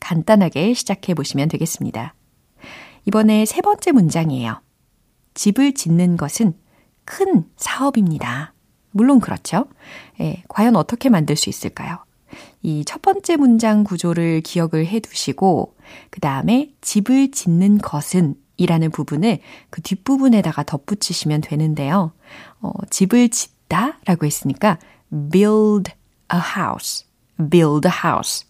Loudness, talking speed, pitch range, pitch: -18 LUFS, 290 characters per minute, 160-220 Hz, 185 Hz